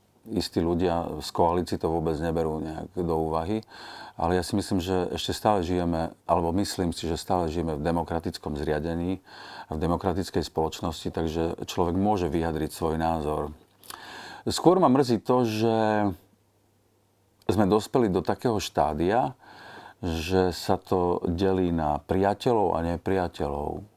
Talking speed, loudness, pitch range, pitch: 140 wpm, -27 LUFS, 80-100 Hz, 90 Hz